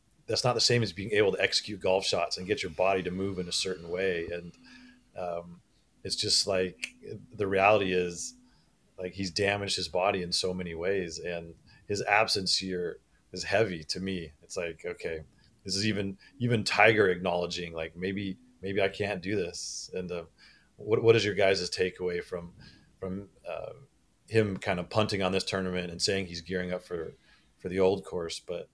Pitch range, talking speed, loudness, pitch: 85-100 Hz, 190 wpm, -29 LUFS, 95 Hz